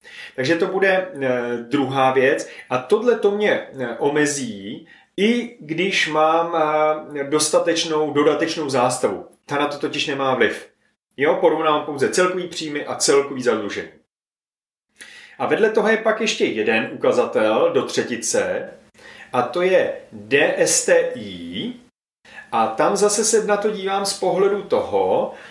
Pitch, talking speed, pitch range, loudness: 185 Hz, 125 wpm, 150-245 Hz, -19 LUFS